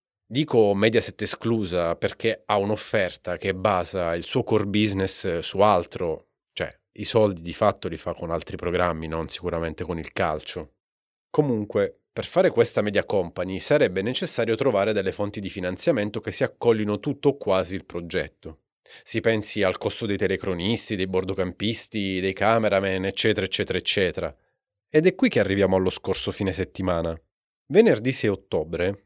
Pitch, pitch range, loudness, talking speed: 100 Hz, 90-110 Hz, -24 LUFS, 155 wpm